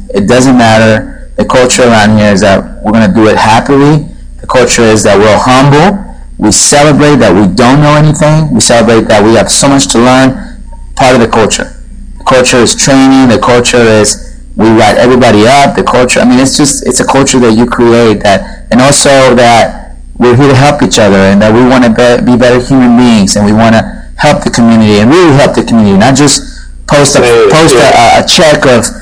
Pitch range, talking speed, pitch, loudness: 110-135 Hz, 215 wpm, 120 Hz, -4 LUFS